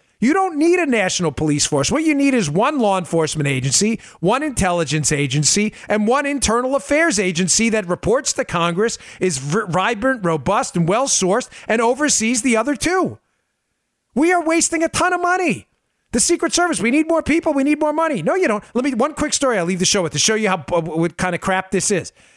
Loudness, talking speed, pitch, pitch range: -18 LUFS, 210 wpm, 225 Hz, 185-290 Hz